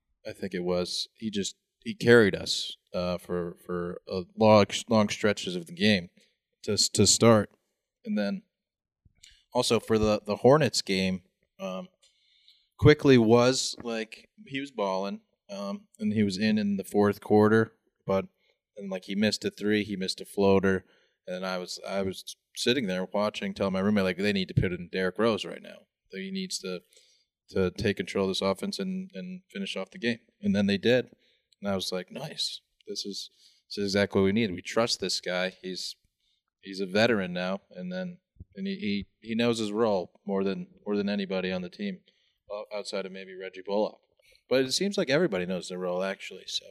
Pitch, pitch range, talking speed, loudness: 100 Hz, 95-120 Hz, 195 wpm, -28 LUFS